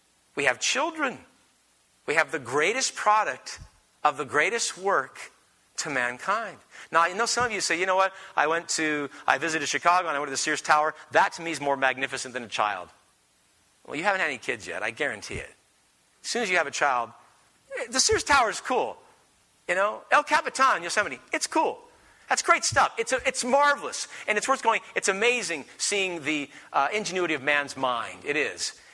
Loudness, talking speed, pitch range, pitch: -25 LUFS, 200 wpm, 140-240 Hz, 170 Hz